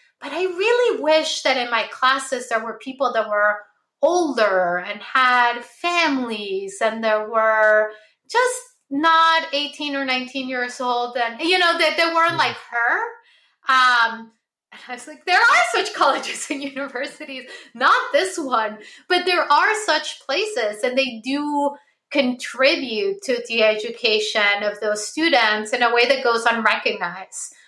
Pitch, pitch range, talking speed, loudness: 255 Hz, 225-310 Hz, 155 wpm, -19 LUFS